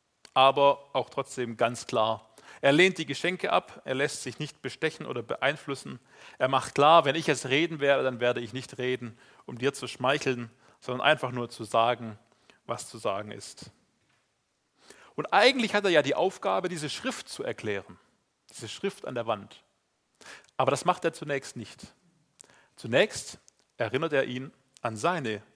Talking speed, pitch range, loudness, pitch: 165 wpm, 125-155 Hz, -28 LUFS, 135 Hz